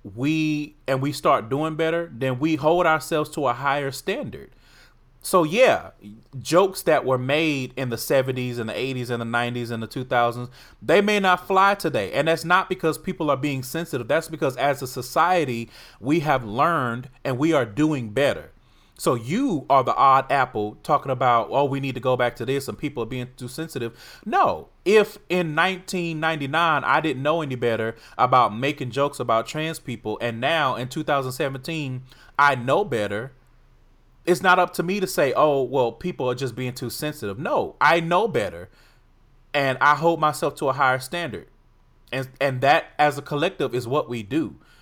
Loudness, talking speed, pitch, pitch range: -22 LUFS, 185 wpm, 140 Hz, 125-160 Hz